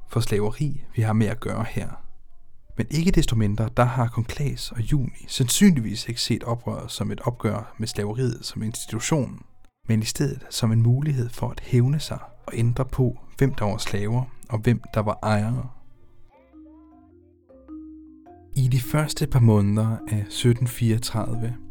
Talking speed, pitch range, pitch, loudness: 160 wpm, 110-130 Hz, 120 Hz, -24 LUFS